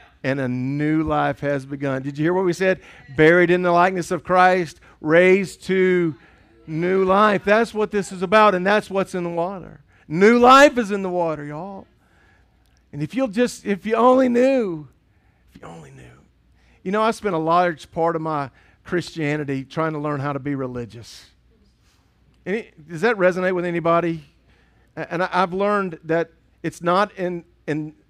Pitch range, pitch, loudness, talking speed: 150-190 Hz, 175 Hz, -19 LUFS, 175 wpm